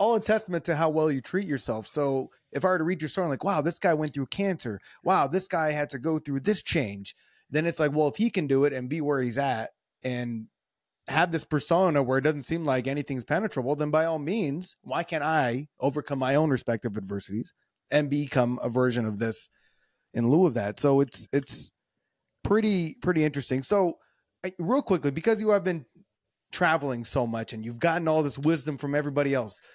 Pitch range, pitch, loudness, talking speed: 130-165 Hz, 150 Hz, -27 LUFS, 215 wpm